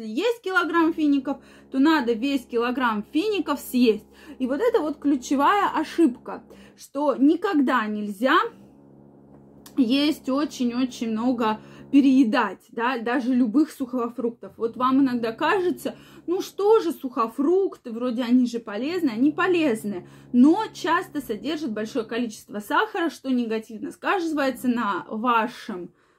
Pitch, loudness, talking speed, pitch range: 265 Hz, -23 LUFS, 120 wpm, 235-305 Hz